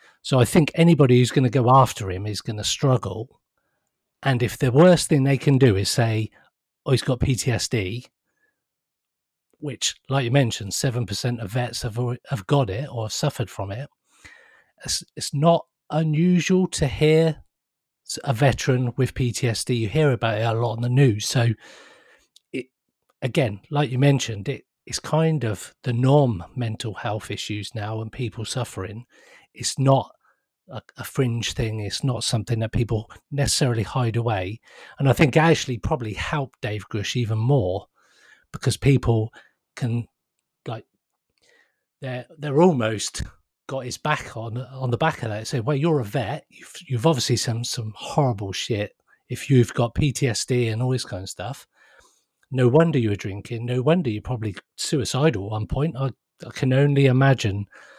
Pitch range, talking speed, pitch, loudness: 110-140 Hz, 165 wpm, 125 Hz, -22 LUFS